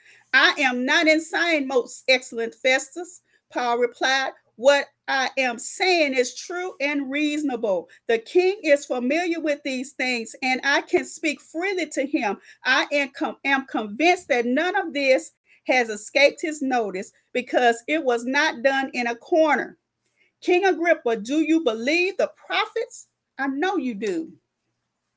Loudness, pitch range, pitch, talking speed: -22 LUFS, 255-330 Hz, 285 Hz, 145 wpm